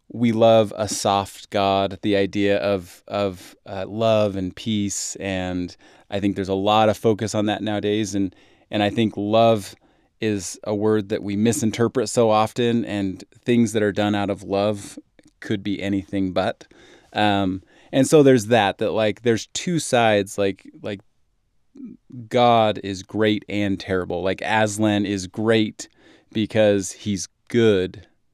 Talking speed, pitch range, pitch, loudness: 155 wpm, 100-110 Hz, 105 Hz, -21 LUFS